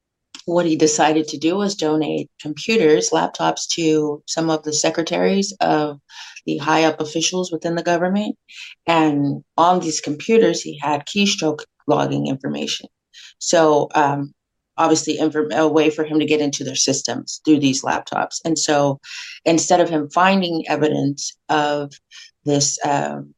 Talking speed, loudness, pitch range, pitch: 145 wpm, -19 LUFS, 145-165 Hz, 155 Hz